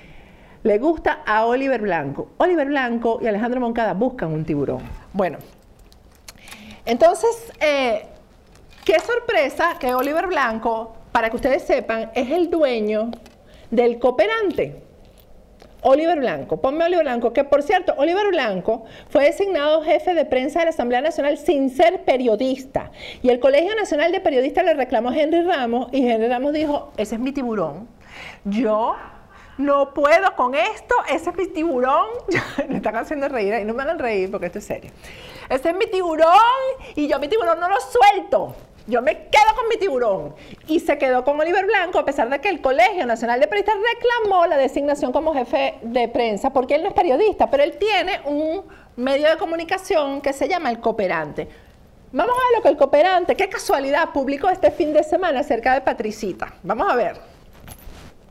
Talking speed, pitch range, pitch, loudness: 175 wpm, 245-350 Hz, 290 Hz, -20 LUFS